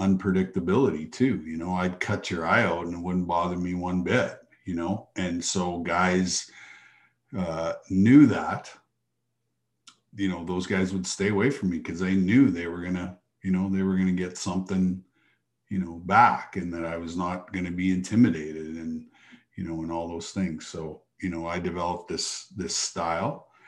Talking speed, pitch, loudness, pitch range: 180 wpm, 90 Hz, -26 LUFS, 85-95 Hz